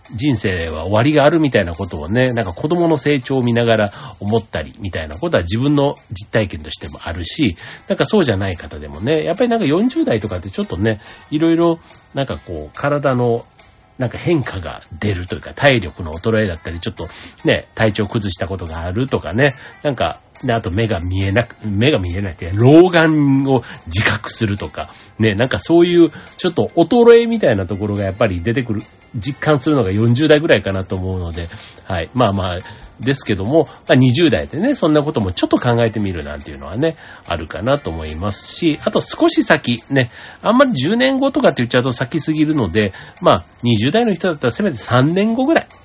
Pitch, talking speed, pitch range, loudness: 115 Hz, 395 characters per minute, 95-150 Hz, -17 LUFS